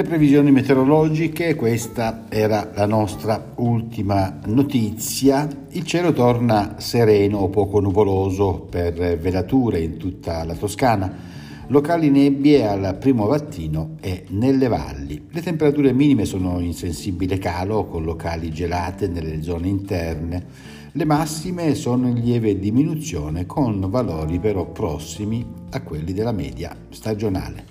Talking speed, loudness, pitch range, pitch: 125 wpm, -20 LUFS, 90-135 Hz, 105 Hz